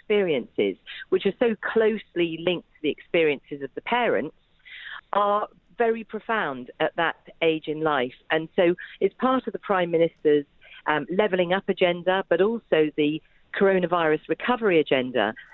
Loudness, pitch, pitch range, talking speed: -24 LUFS, 180 Hz, 155-215 Hz, 145 wpm